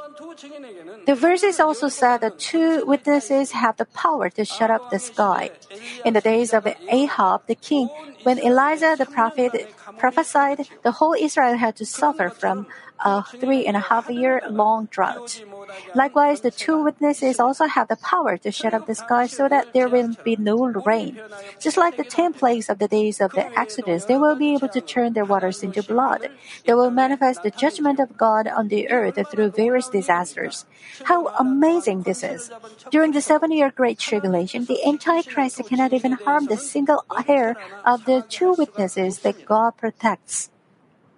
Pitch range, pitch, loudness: 215-285 Hz, 245 Hz, -20 LUFS